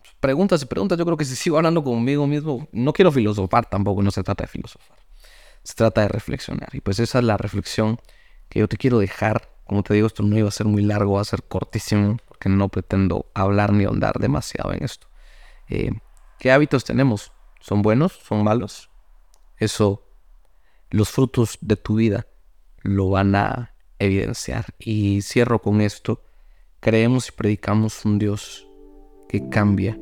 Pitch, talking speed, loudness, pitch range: 105 Hz, 175 wpm, -21 LUFS, 100-120 Hz